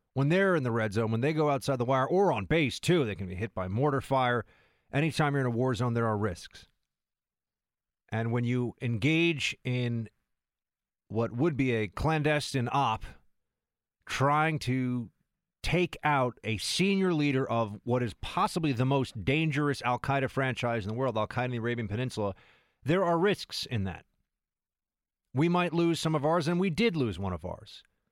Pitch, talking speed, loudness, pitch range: 130 Hz, 185 wpm, -29 LUFS, 115-150 Hz